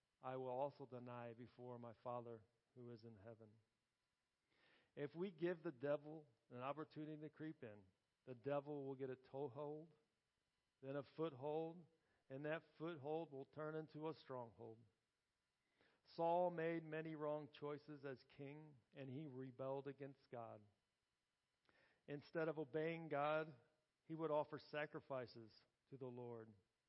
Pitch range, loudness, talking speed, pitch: 120-155 Hz, -51 LUFS, 135 wpm, 140 Hz